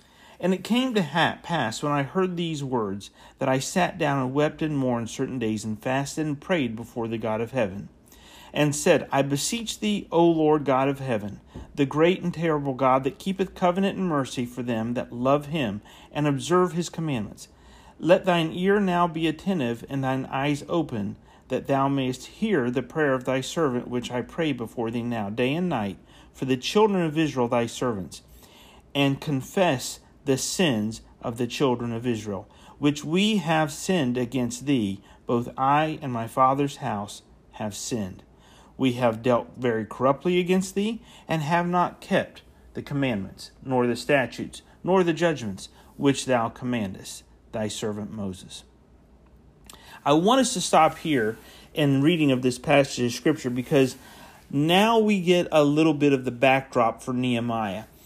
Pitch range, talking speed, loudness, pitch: 120-160 Hz, 170 wpm, -25 LUFS, 135 Hz